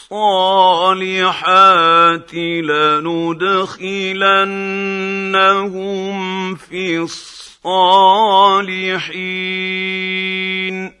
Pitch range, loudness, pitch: 185-195 Hz, -14 LUFS, 190 Hz